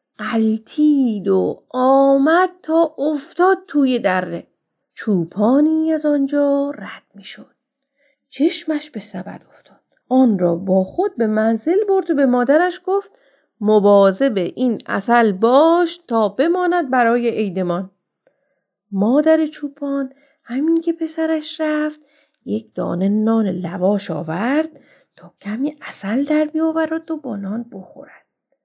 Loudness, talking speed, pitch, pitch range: -18 LUFS, 120 wpm, 270 Hz, 215-310 Hz